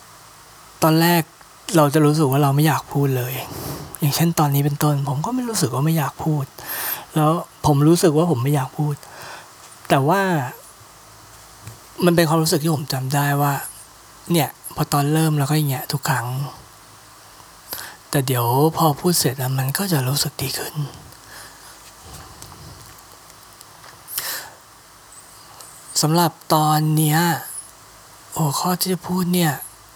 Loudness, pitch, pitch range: -20 LUFS, 150 Hz, 140-160 Hz